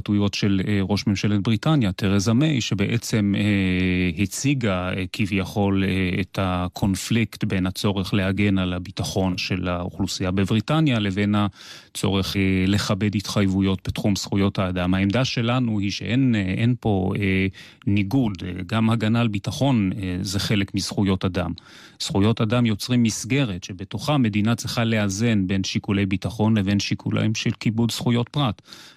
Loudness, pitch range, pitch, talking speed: -22 LUFS, 95-115 Hz, 100 Hz, 120 wpm